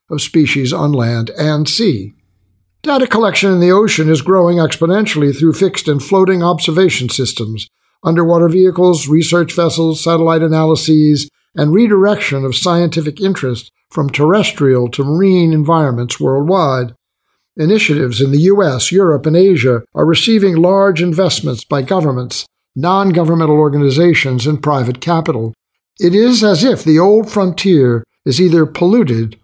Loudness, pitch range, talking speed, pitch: -12 LUFS, 140-185 Hz, 135 wpm, 160 Hz